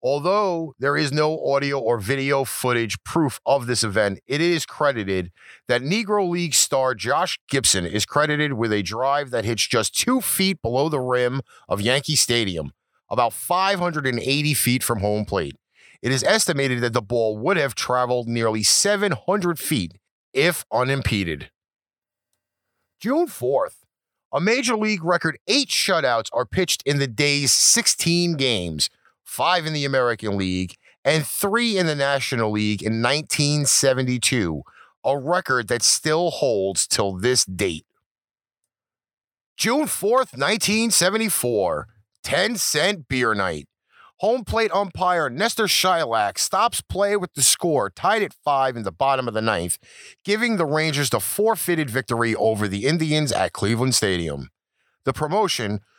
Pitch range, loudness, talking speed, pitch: 115-175 Hz, -21 LUFS, 145 wpm, 140 Hz